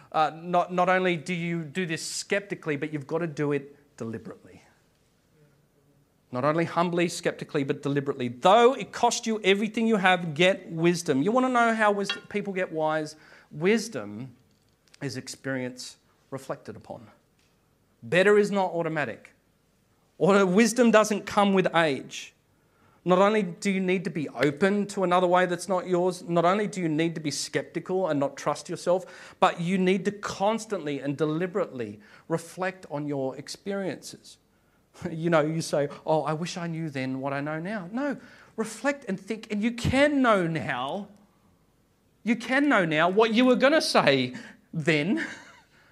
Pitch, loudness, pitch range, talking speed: 175 Hz, -26 LUFS, 150-200 Hz, 165 wpm